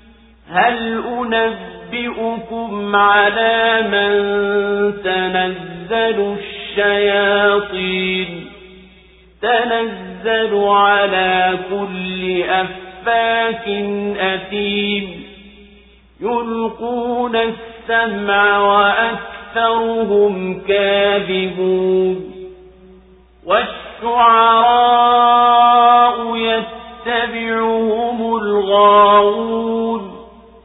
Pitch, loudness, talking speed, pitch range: 205 Hz, -15 LUFS, 35 wpm, 200-230 Hz